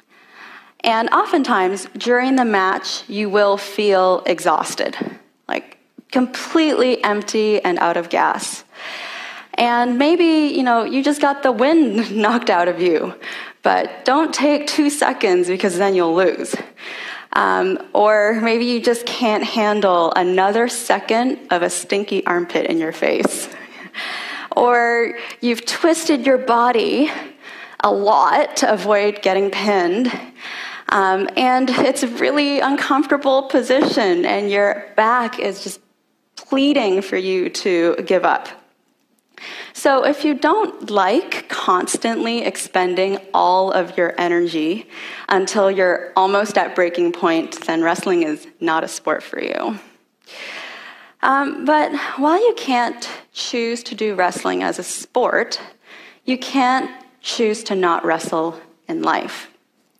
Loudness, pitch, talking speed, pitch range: -18 LUFS, 235 Hz, 130 wpm, 195-280 Hz